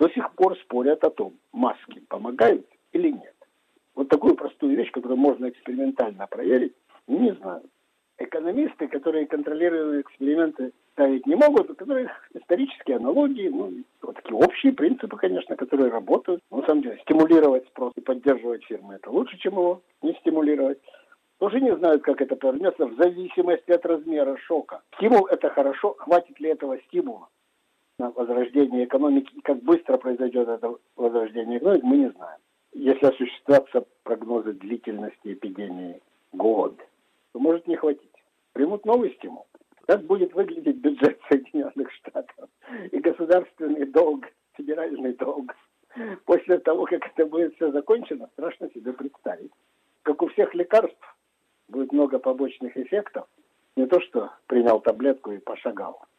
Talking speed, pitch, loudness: 140 wpm, 160 Hz, -23 LUFS